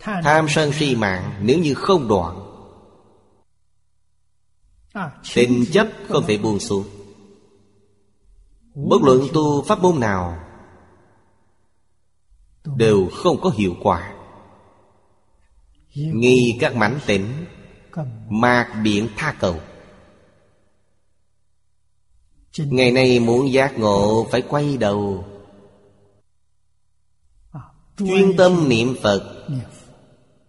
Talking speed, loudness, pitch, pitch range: 90 wpm, -18 LUFS, 100 Hz, 100-125 Hz